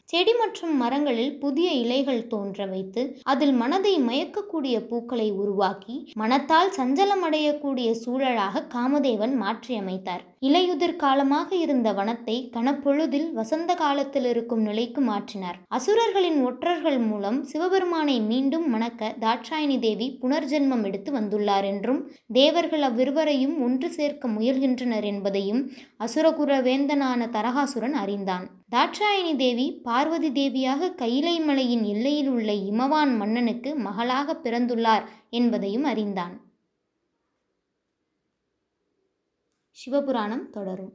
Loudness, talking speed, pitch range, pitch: -24 LUFS, 95 wpm, 225-295 Hz, 260 Hz